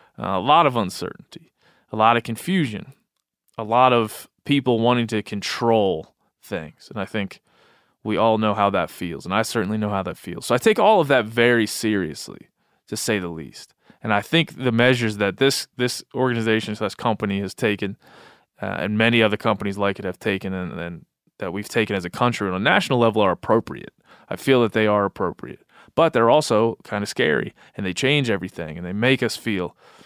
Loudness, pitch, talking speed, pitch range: -21 LUFS, 110 Hz, 205 wpm, 100-120 Hz